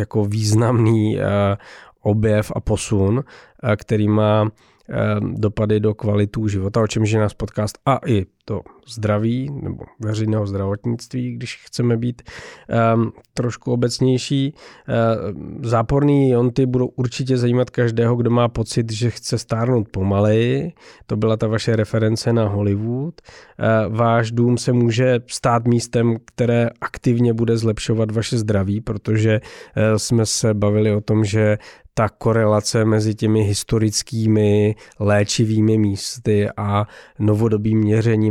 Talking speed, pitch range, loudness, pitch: 125 wpm, 105-120 Hz, -19 LUFS, 110 Hz